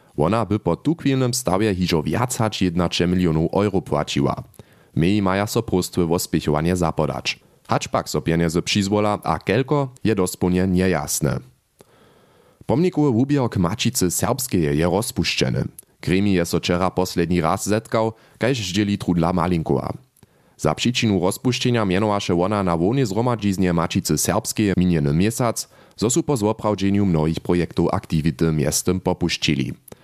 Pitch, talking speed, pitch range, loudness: 95 Hz, 135 wpm, 85-110 Hz, -21 LUFS